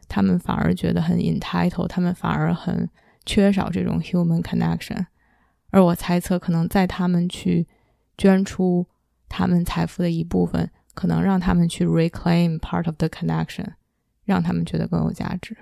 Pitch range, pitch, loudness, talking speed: 165-185 Hz, 175 Hz, -22 LUFS, 385 characters per minute